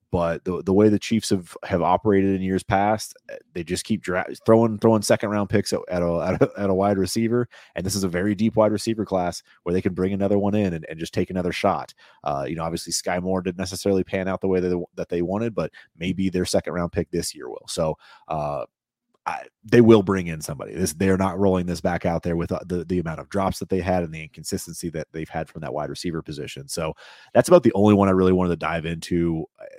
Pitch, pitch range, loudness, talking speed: 95 Hz, 85-100 Hz, -23 LUFS, 250 wpm